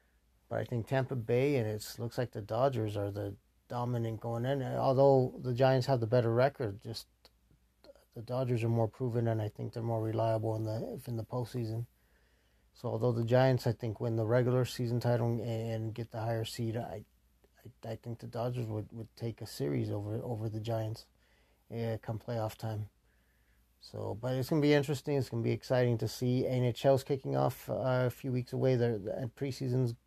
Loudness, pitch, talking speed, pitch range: -33 LUFS, 115 Hz, 190 wpm, 110-125 Hz